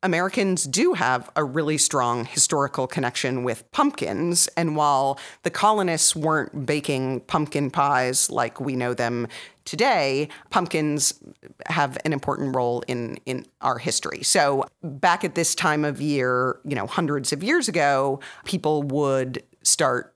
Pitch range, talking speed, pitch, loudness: 130-165 Hz, 145 wpm, 145 Hz, -23 LUFS